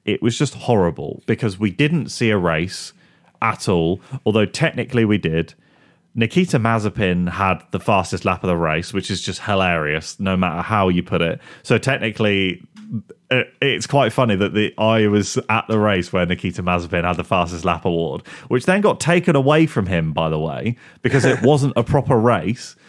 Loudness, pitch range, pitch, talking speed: -19 LUFS, 90-125 Hz, 105 Hz, 185 wpm